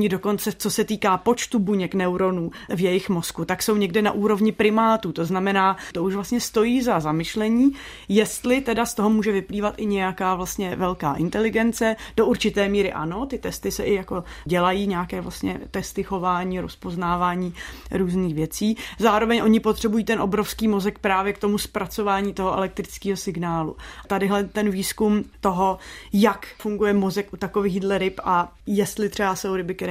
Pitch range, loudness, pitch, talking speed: 185-215 Hz, -23 LUFS, 200 Hz, 165 wpm